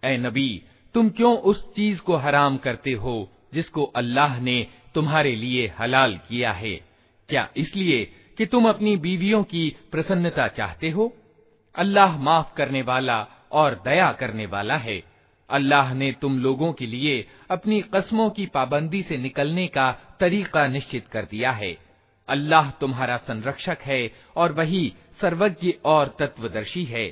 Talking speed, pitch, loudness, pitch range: 145 wpm, 140 Hz, -23 LUFS, 125-175 Hz